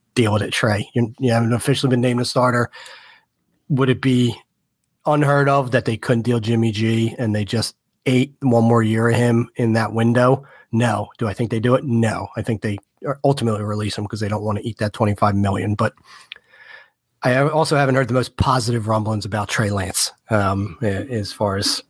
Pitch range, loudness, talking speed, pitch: 105-125 Hz, -19 LUFS, 205 wpm, 115 Hz